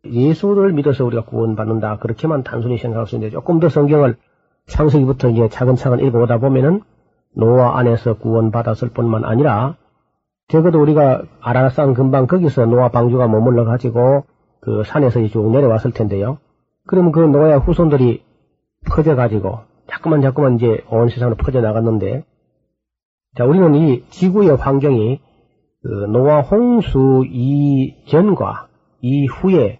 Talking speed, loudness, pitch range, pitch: 330 characters per minute, -15 LUFS, 115-150 Hz, 130 Hz